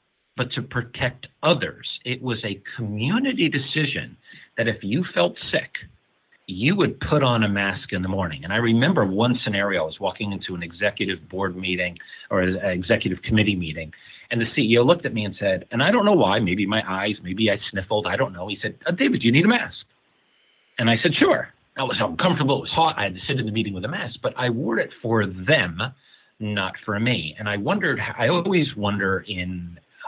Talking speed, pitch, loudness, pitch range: 215 wpm, 110 Hz, -23 LUFS, 95-125 Hz